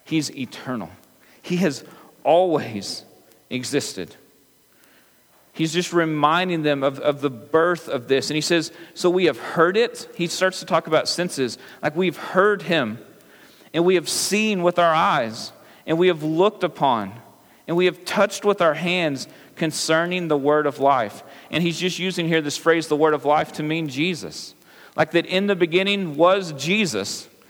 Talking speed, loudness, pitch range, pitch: 170 wpm, -21 LUFS, 150-180 Hz, 165 Hz